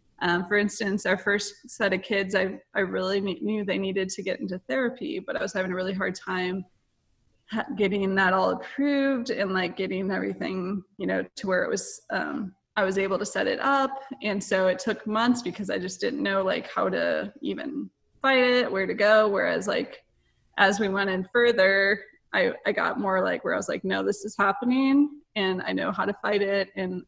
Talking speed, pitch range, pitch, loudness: 215 wpm, 190-230 Hz, 200 Hz, -26 LUFS